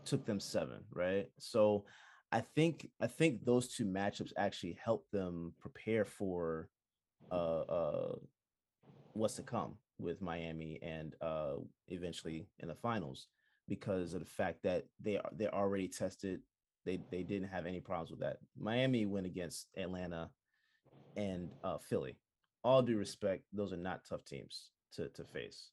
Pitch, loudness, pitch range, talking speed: 95 Hz, -40 LUFS, 85-105 Hz, 150 wpm